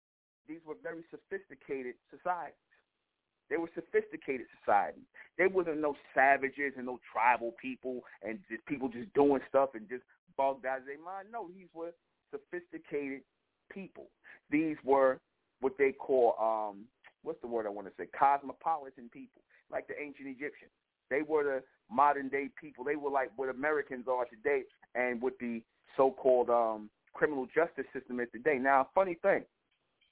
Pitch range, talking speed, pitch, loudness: 130-165 Hz, 160 wpm, 140 Hz, -33 LUFS